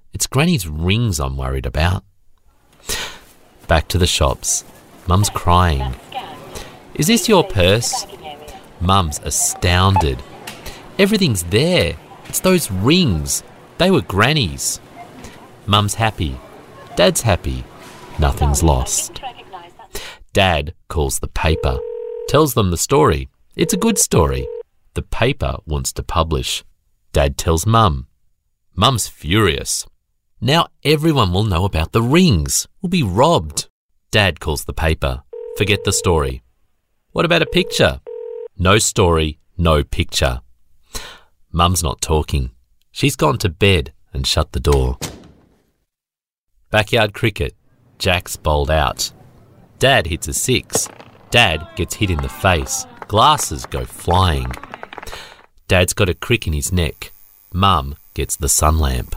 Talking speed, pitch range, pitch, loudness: 120 wpm, 75-115 Hz, 90 Hz, -17 LUFS